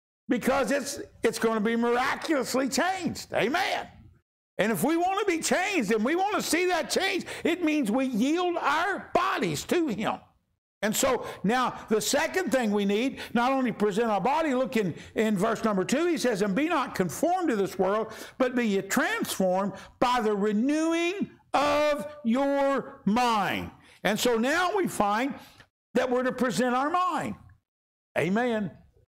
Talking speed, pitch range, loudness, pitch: 165 wpm, 225-295 Hz, -27 LUFS, 255 Hz